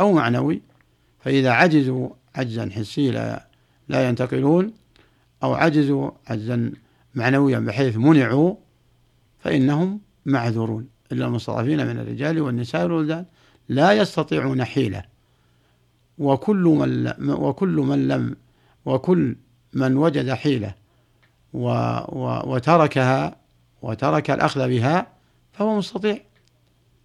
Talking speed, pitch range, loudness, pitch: 95 wpm, 115-155 Hz, -21 LUFS, 130 Hz